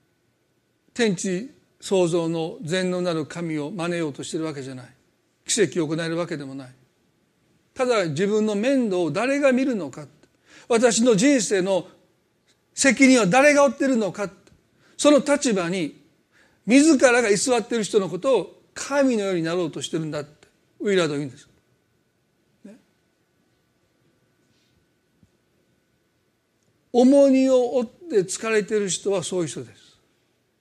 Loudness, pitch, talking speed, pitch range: -21 LUFS, 195 Hz, 270 characters per minute, 165-255 Hz